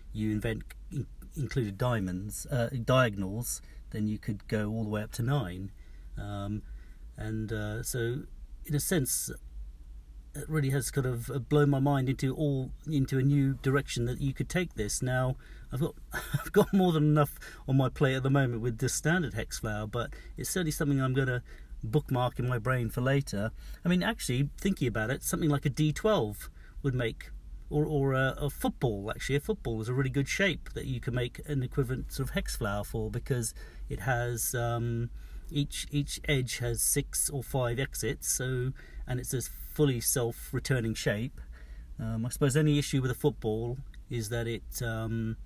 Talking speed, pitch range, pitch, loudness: 190 wpm, 110-140 Hz, 125 Hz, -31 LUFS